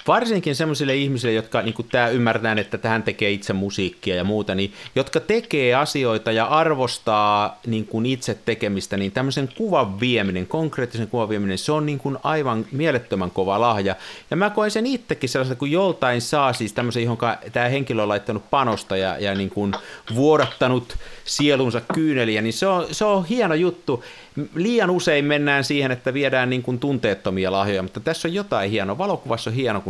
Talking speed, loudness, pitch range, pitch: 175 wpm, -21 LUFS, 110-150 Hz, 125 Hz